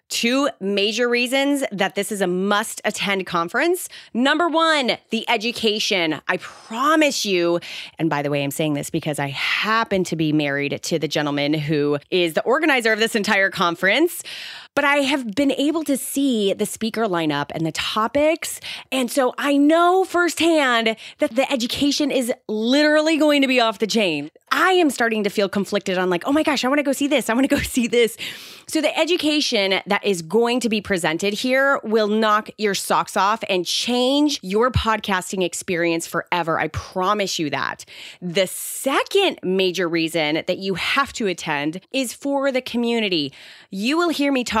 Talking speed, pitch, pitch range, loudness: 180 wpm, 220 Hz, 185-275 Hz, -20 LUFS